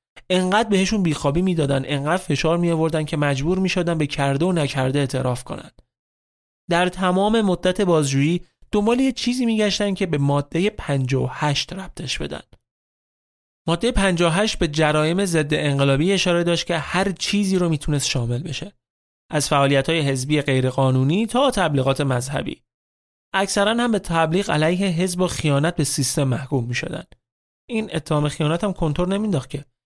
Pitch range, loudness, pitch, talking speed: 140-185 Hz, -20 LUFS, 160 Hz, 145 wpm